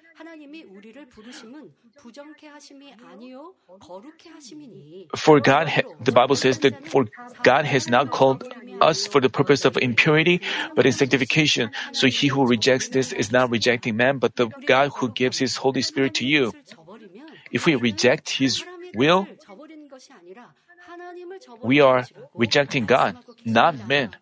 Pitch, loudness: 145 Hz, -20 LUFS